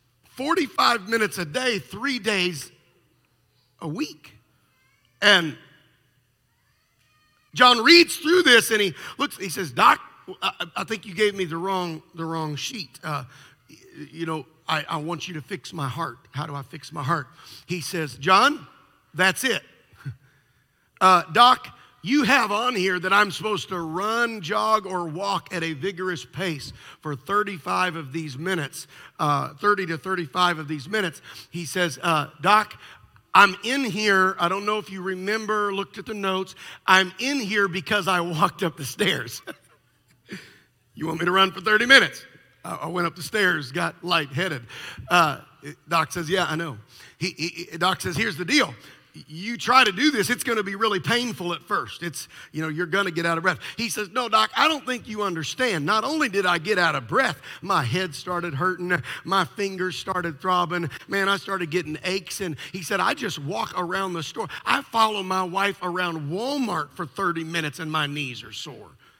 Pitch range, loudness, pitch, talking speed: 160-205 Hz, -23 LUFS, 180 Hz, 185 wpm